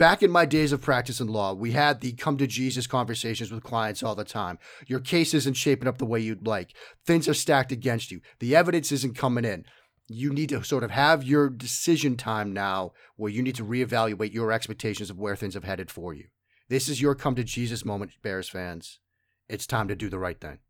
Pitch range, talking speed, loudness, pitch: 105-140 Hz, 230 wpm, -26 LUFS, 120 Hz